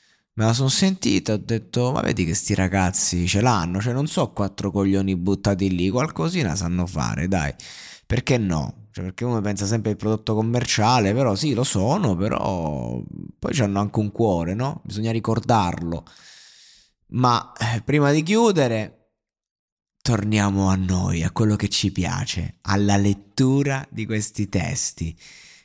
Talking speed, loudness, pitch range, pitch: 150 wpm, -22 LUFS, 95-120 Hz, 105 Hz